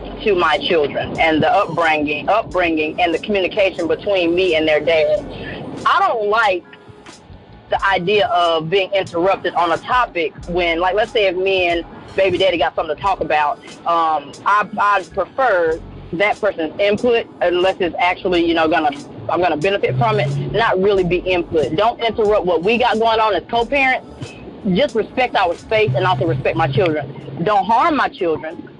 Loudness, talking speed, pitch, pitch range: -17 LUFS, 175 wpm, 185 Hz, 165-215 Hz